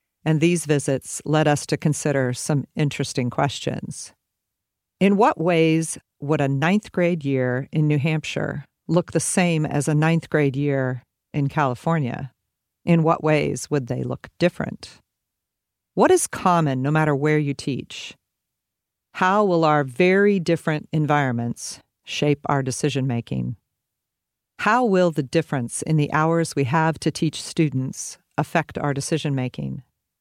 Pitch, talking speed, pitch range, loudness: 150 Hz, 145 wpm, 140-165 Hz, -22 LUFS